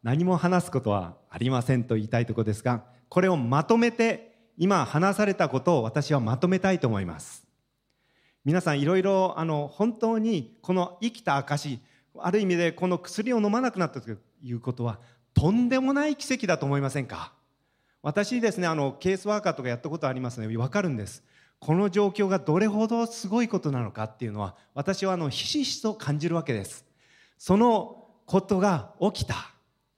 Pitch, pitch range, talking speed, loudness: 170 Hz, 125-205 Hz, 370 characters per minute, -26 LUFS